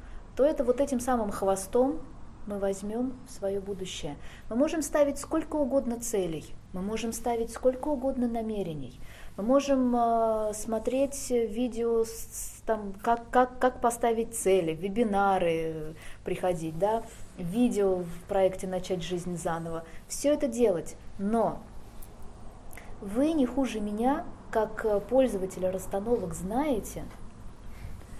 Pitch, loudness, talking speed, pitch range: 215 Hz, -29 LUFS, 115 wpm, 180-245 Hz